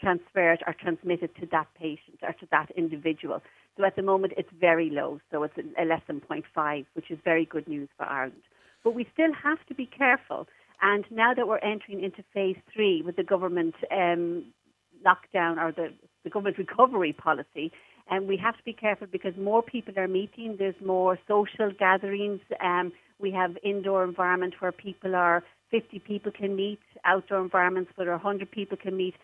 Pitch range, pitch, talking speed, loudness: 170-200 Hz, 190 Hz, 185 wpm, -28 LUFS